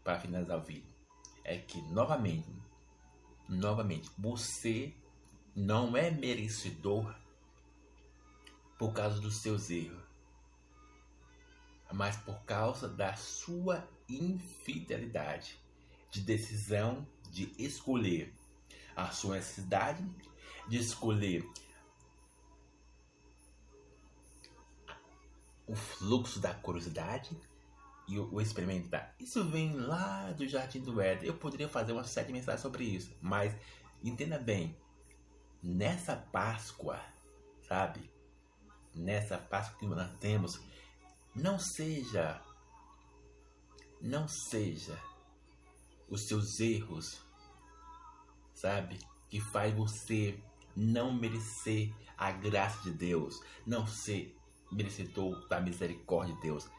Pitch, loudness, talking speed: 100 Hz, -38 LUFS, 95 wpm